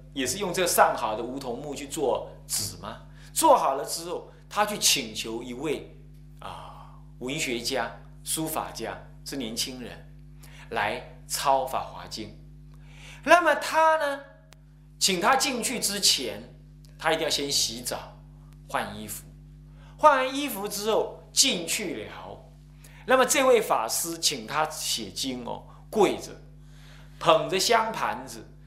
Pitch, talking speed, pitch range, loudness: 150 Hz, 185 characters per minute, 145-195 Hz, -25 LUFS